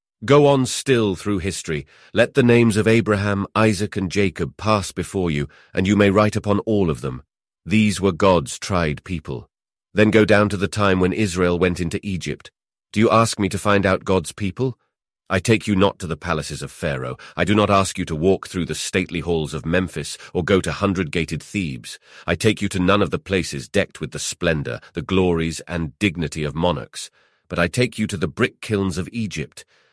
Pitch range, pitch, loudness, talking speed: 85-105 Hz, 100 Hz, -20 LUFS, 210 wpm